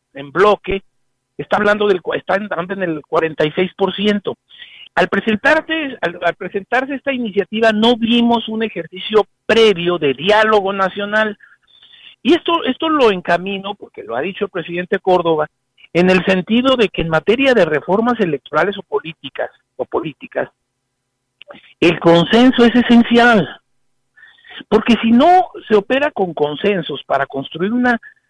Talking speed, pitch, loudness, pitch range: 140 wpm, 200 Hz, -15 LUFS, 170-235 Hz